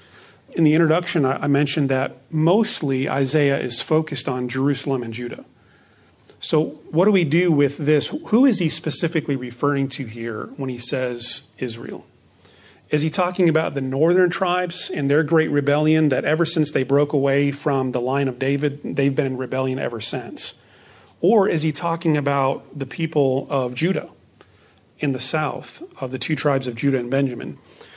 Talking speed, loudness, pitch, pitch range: 170 wpm, -21 LUFS, 140 Hz, 130-160 Hz